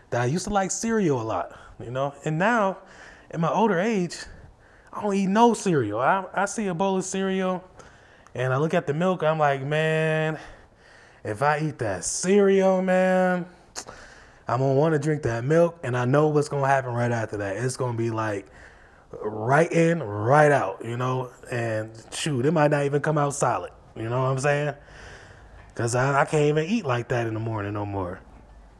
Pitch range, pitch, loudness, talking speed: 120-175 Hz, 145 Hz, -24 LUFS, 200 wpm